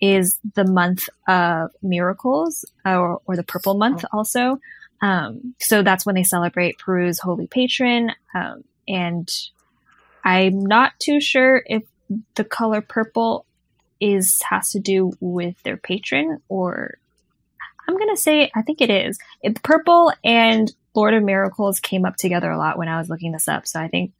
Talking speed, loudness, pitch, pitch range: 165 wpm, -19 LUFS, 200 Hz, 180-245 Hz